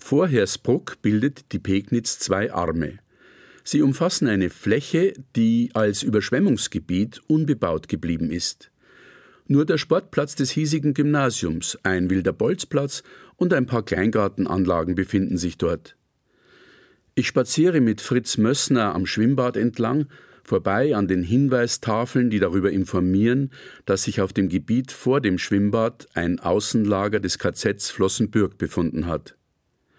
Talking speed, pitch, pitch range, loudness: 125 wpm, 110 Hz, 95-135 Hz, -22 LUFS